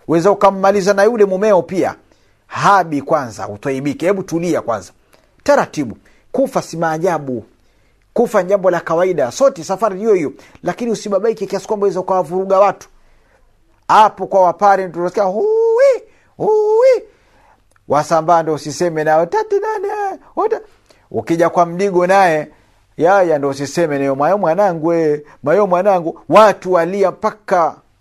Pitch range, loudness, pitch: 165-215 Hz, -15 LUFS, 190 Hz